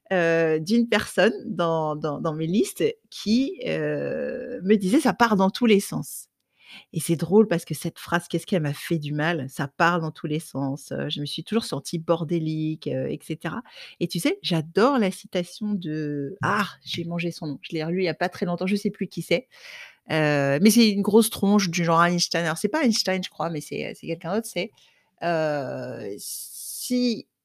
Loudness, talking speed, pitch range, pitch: -24 LUFS, 210 wpm, 160-210 Hz, 175 Hz